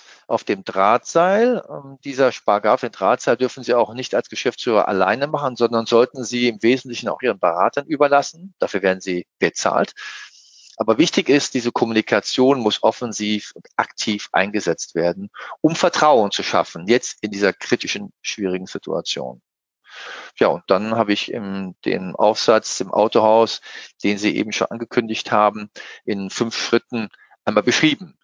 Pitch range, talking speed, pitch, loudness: 105-130 Hz, 150 wpm, 115 Hz, -19 LUFS